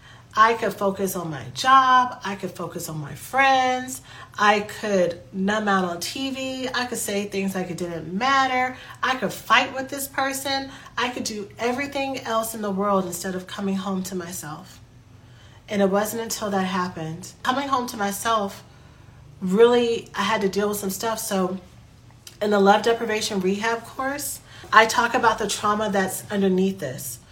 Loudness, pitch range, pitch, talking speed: -23 LUFS, 185-235 Hz, 205 Hz, 175 wpm